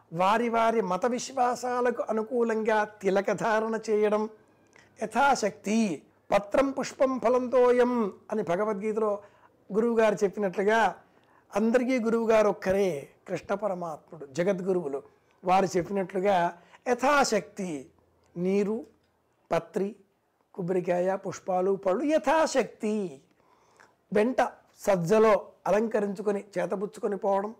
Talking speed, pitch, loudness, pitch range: 75 wpm, 210 Hz, -27 LUFS, 195-230 Hz